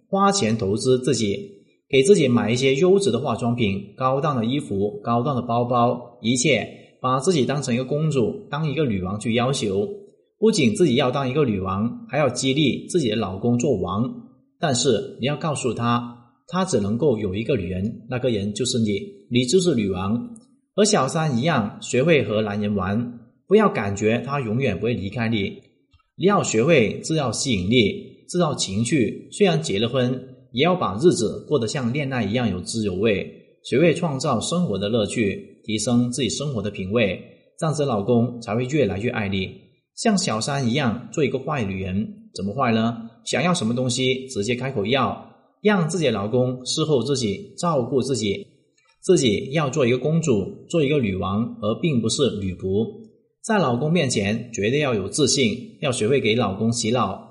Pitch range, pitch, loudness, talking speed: 110-150 Hz, 125 Hz, -22 LUFS, 270 characters per minute